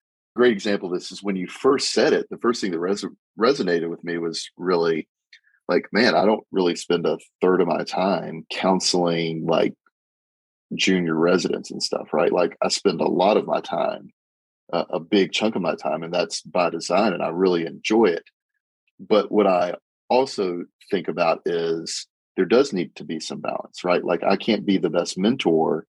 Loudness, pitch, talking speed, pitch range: -22 LUFS, 90 Hz, 195 wpm, 85-100 Hz